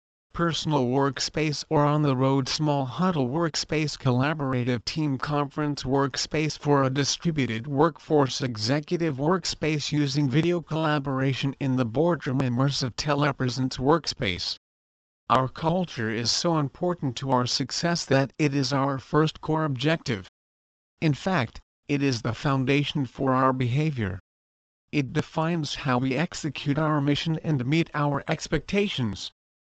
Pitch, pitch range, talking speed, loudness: 140 Hz, 130-155 Hz, 130 wpm, -26 LUFS